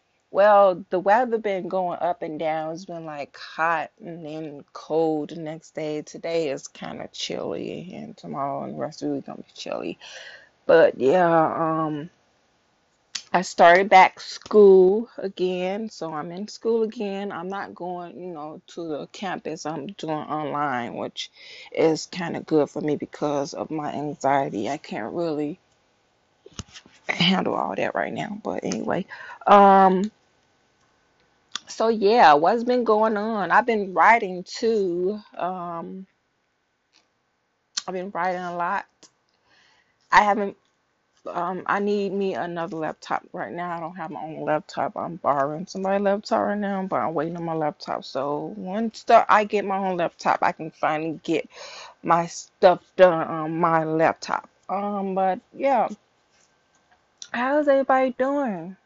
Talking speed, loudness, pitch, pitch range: 150 wpm, -23 LUFS, 175 Hz, 155-200 Hz